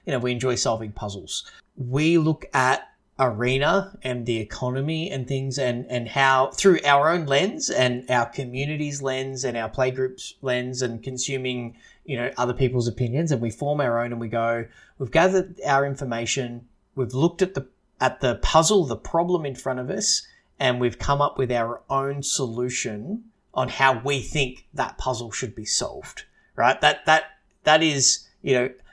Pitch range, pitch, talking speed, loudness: 125-145 Hz, 130 Hz, 180 wpm, -23 LUFS